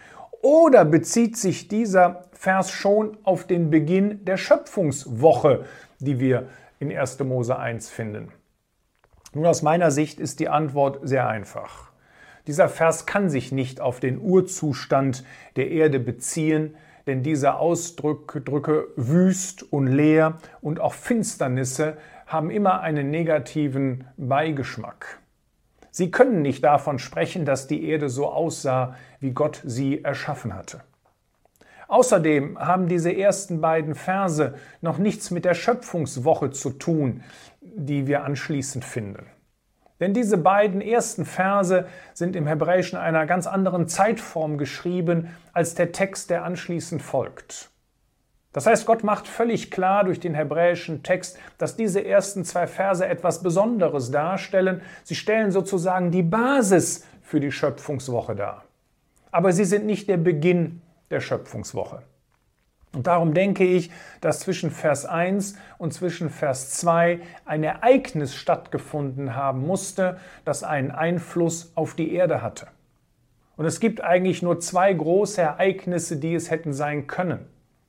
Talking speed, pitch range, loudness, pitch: 135 wpm, 145-185 Hz, -23 LUFS, 165 Hz